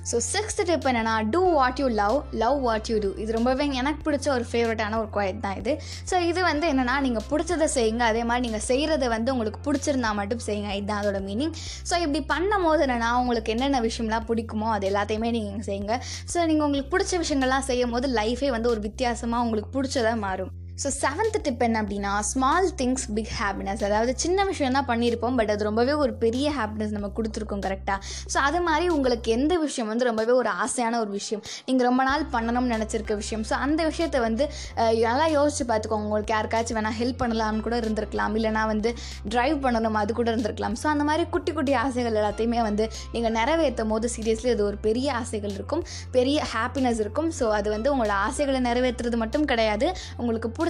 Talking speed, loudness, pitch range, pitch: 190 wpm, -25 LUFS, 220-280 Hz, 235 Hz